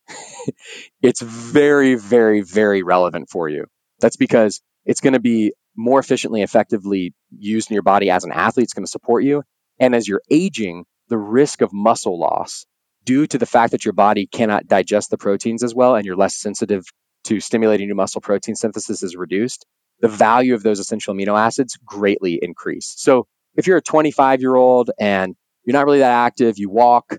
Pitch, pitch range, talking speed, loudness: 110 Hz, 100-125 Hz, 190 wpm, -17 LUFS